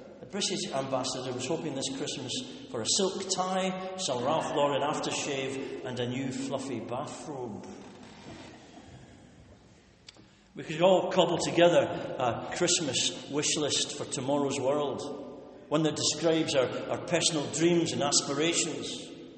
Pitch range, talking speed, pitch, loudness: 135-170 Hz, 125 wpm, 150 Hz, -29 LUFS